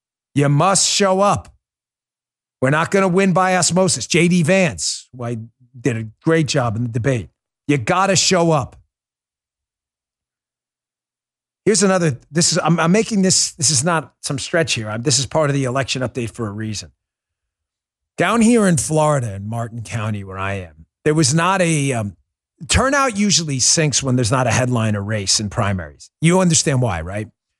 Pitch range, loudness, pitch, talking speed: 110-170 Hz, -17 LUFS, 135 Hz, 180 wpm